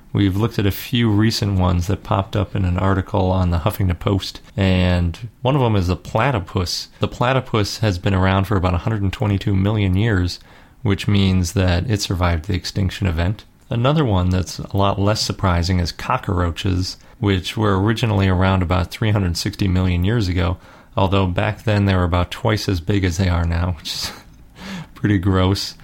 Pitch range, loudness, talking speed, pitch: 90-105 Hz, -19 LUFS, 180 wpm, 100 Hz